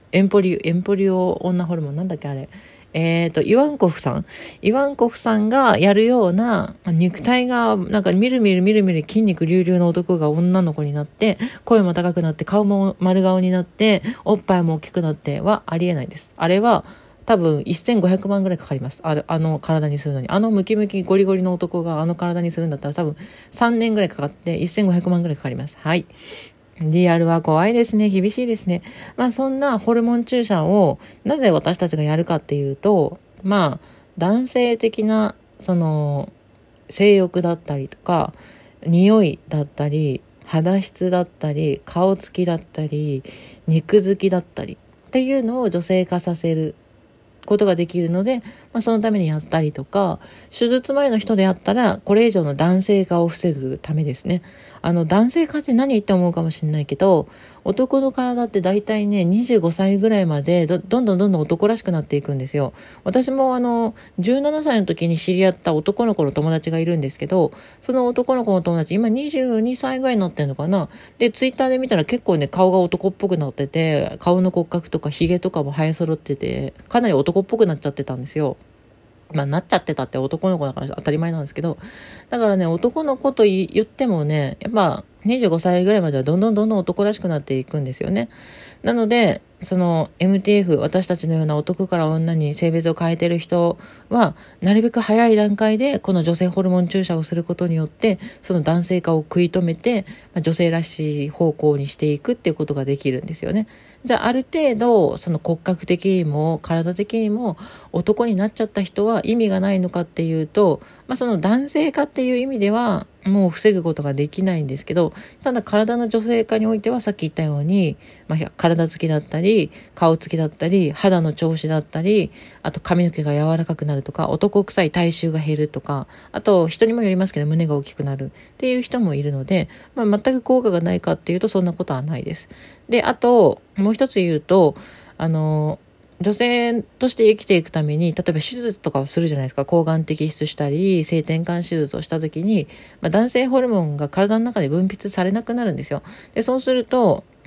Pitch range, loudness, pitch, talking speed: 160-215 Hz, -19 LUFS, 180 Hz, 380 characters per minute